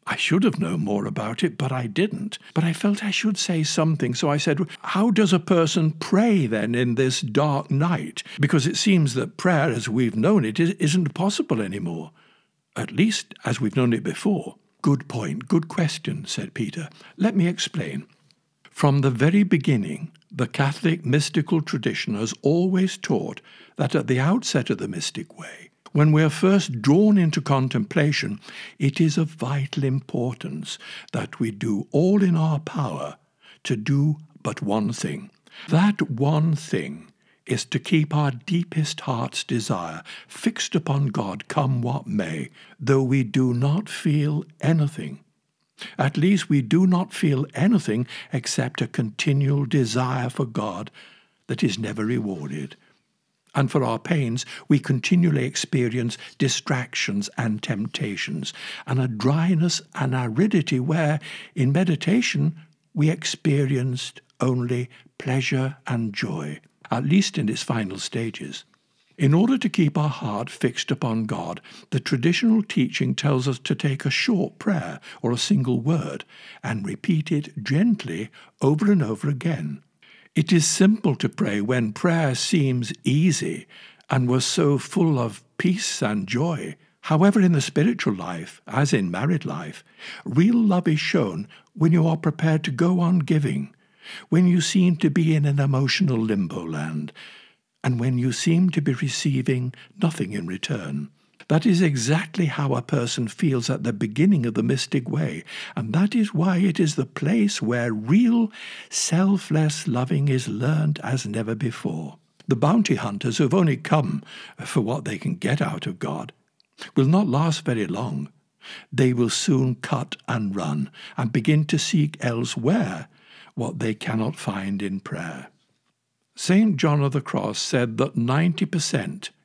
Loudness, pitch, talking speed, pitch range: -23 LUFS, 150 Hz, 155 wpm, 130-175 Hz